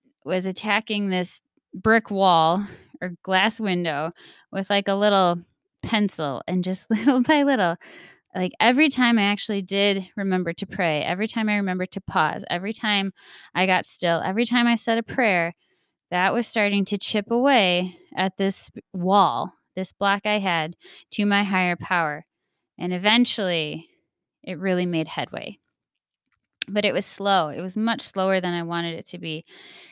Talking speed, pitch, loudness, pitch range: 160 wpm, 195 Hz, -22 LUFS, 180-215 Hz